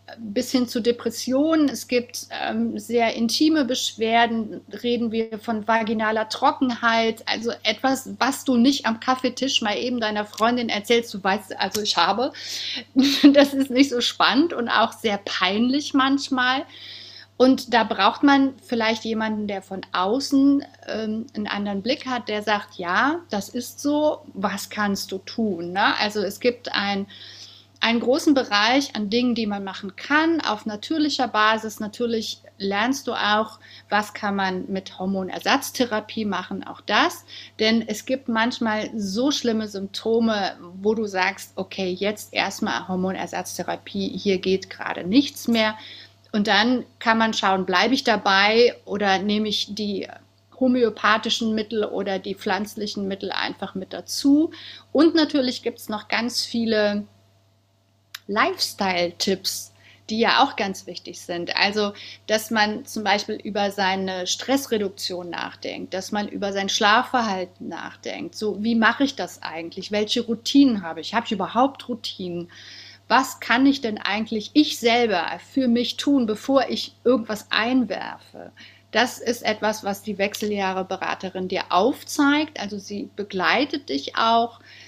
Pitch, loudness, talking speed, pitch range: 220 Hz, -22 LUFS, 145 wpm, 200-245 Hz